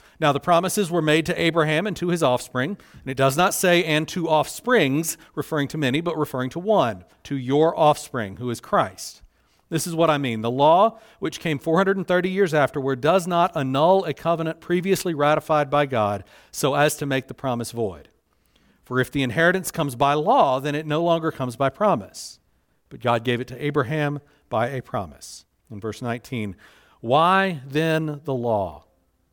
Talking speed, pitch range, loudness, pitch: 185 wpm, 130-165 Hz, -22 LUFS, 150 Hz